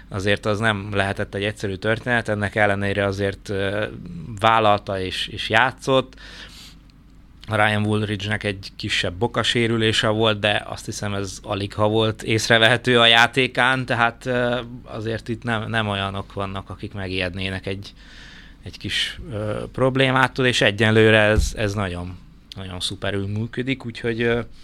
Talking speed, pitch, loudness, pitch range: 130 wpm, 105 Hz, -21 LUFS, 100-115 Hz